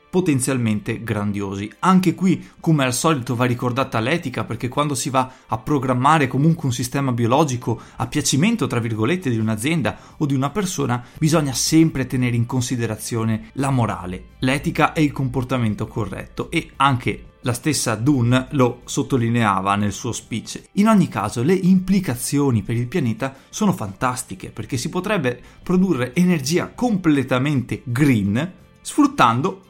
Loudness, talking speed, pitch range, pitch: -20 LUFS, 140 wpm, 120-155 Hz, 130 Hz